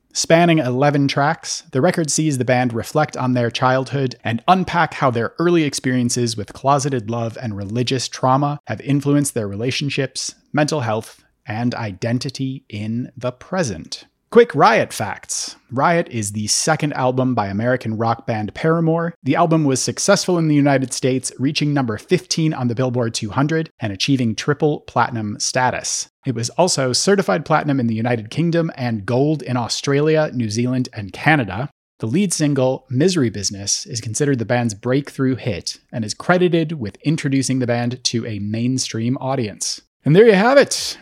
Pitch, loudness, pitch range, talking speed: 130 Hz, -19 LUFS, 120-150 Hz, 165 wpm